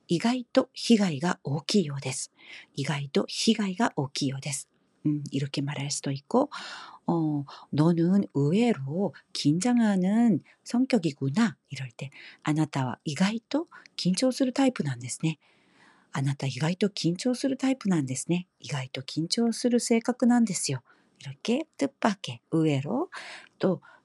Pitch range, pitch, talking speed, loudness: 140-235 Hz, 170 Hz, 290 characters per minute, -28 LUFS